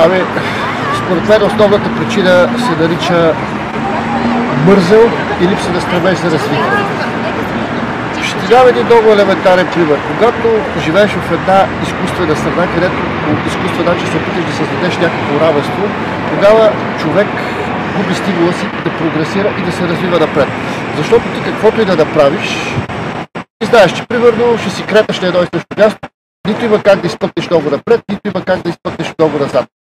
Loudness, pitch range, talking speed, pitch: -12 LUFS, 175-215 Hz, 165 wpm, 195 Hz